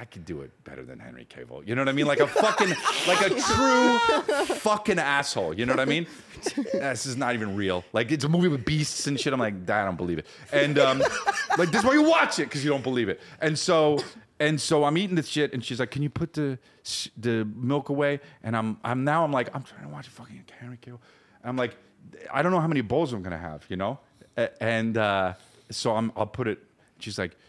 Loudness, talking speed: -25 LUFS, 250 wpm